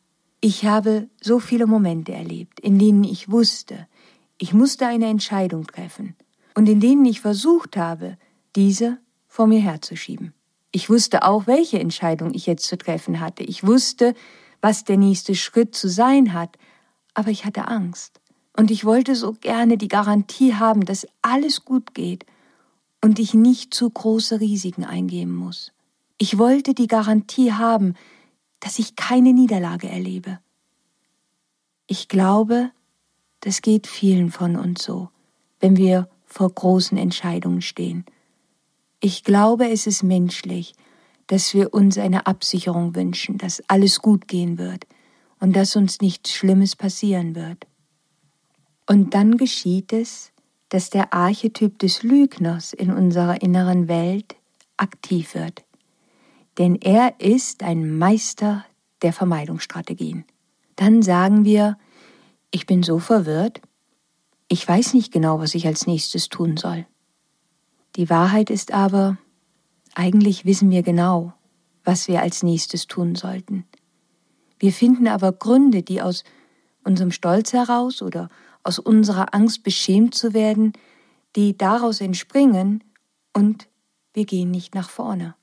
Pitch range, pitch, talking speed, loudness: 180-225 Hz, 195 Hz, 135 wpm, -19 LUFS